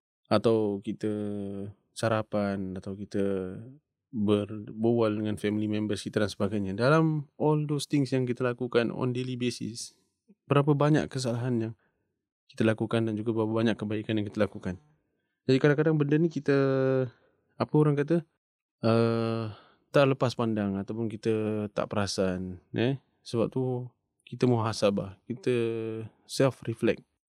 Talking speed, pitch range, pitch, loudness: 130 wpm, 105-130 Hz, 115 Hz, -29 LUFS